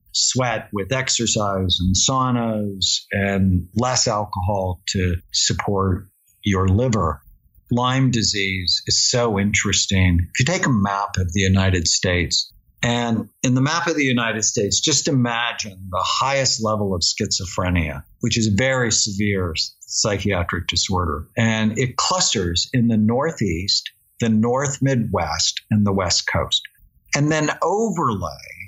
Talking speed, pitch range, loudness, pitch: 135 wpm, 95-120 Hz, -19 LUFS, 105 Hz